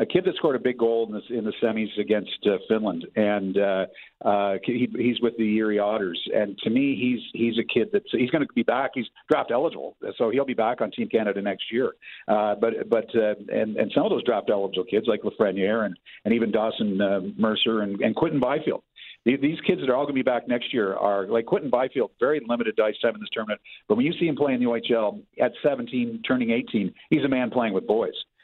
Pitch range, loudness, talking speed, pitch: 105-140 Hz, -25 LUFS, 245 wpm, 115 Hz